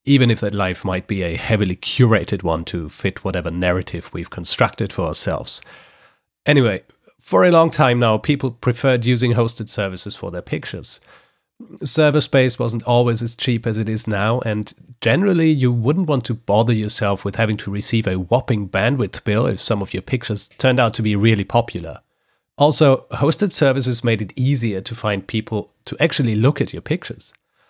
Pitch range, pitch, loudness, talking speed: 100-130 Hz, 115 Hz, -18 LUFS, 180 wpm